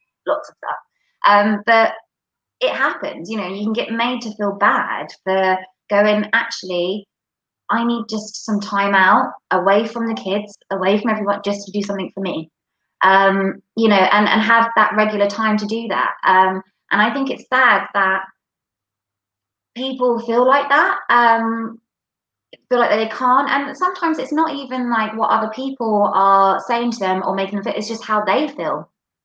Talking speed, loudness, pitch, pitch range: 180 wpm, -17 LUFS, 210 Hz, 195-235 Hz